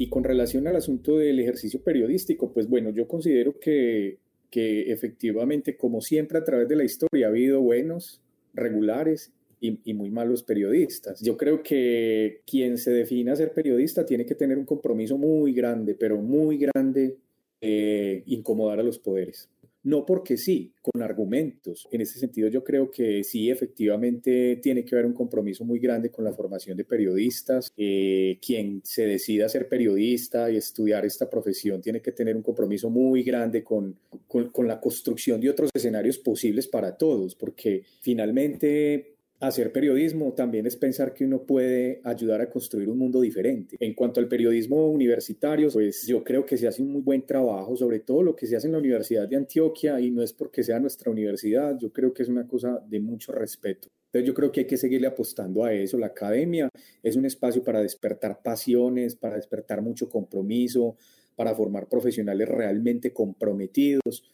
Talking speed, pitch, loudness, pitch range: 180 wpm, 120 Hz, -25 LUFS, 110-135 Hz